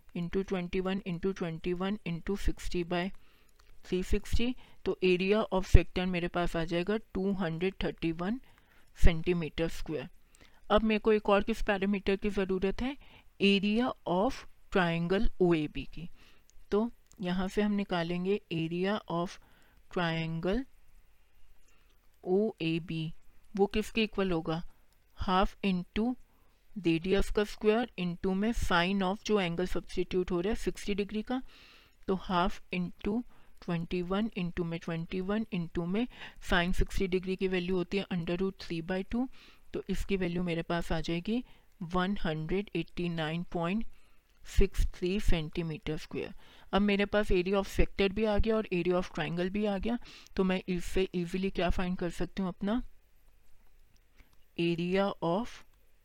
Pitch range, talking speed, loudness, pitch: 175-200 Hz, 150 wpm, -32 LUFS, 185 Hz